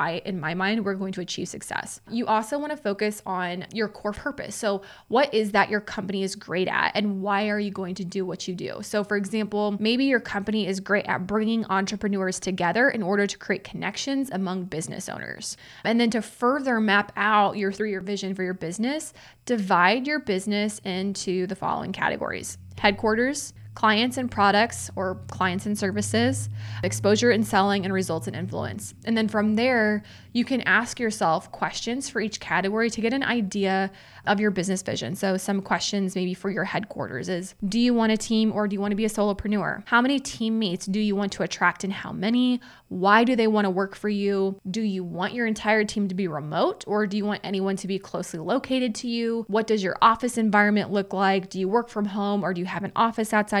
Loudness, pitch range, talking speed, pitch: -25 LUFS, 190-220 Hz, 215 wpm, 205 Hz